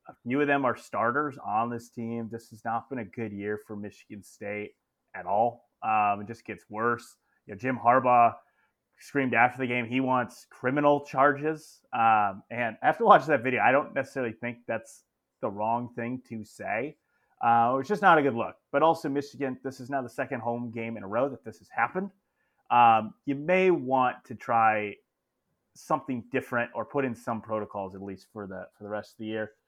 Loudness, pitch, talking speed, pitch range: -27 LUFS, 120 Hz, 205 wpm, 110-135 Hz